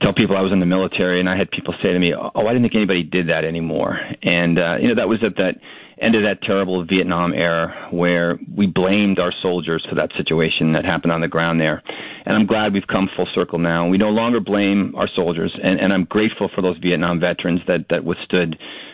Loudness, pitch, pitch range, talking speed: -18 LUFS, 90 Hz, 85-100 Hz, 240 wpm